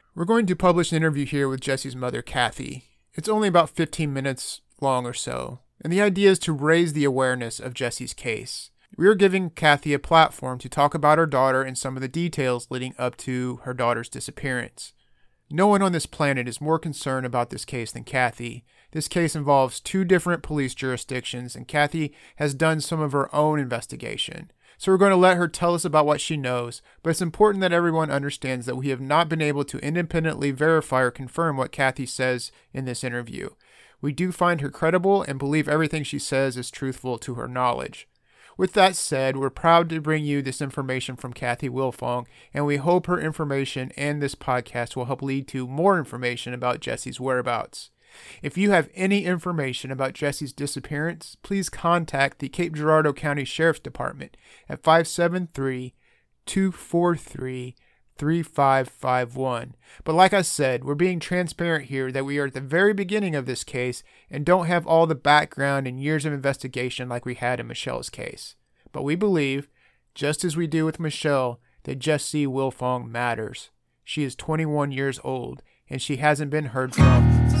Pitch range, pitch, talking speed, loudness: 130-160 Hz, 145 Hz, 185 wpm, -24 LUFS